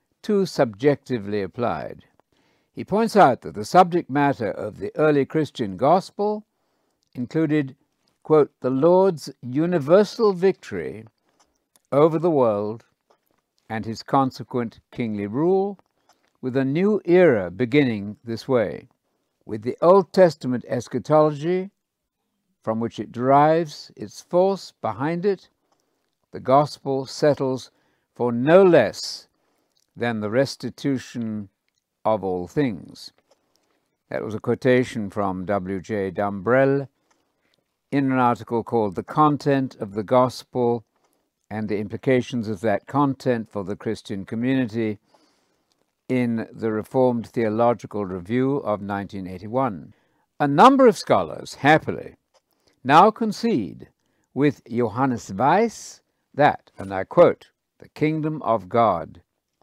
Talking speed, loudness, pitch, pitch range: 115 wpm, -22 LUFS, 130 Hz, 110-155 Hz